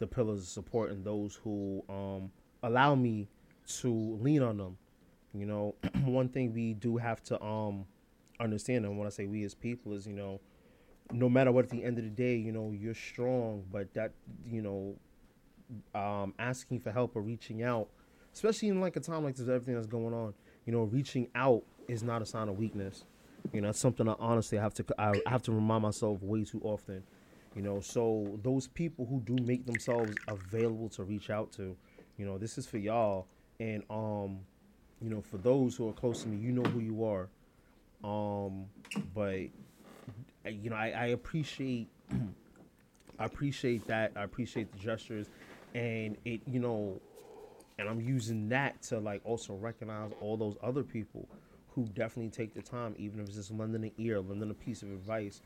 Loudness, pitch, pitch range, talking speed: -36 LUFS, 110 Hz, 105-120 Hz, 195 wpm